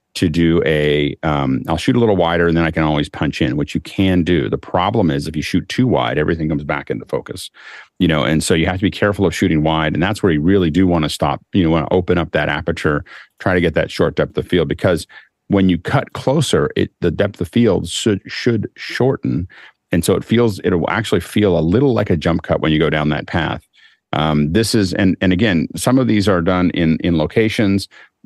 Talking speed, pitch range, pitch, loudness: 245 wpm, 80-95 Hz, 85 Hz, -16 LUFS